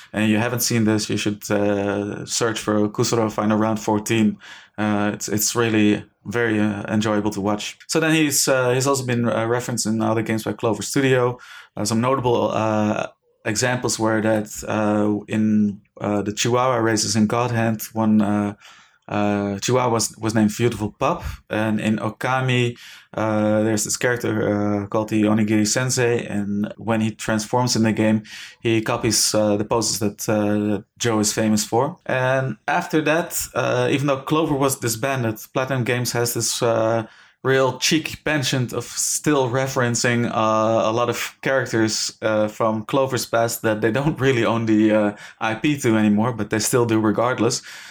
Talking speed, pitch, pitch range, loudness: 170 wpm, 110 Hz, 105-125 Hz, -21 LUFS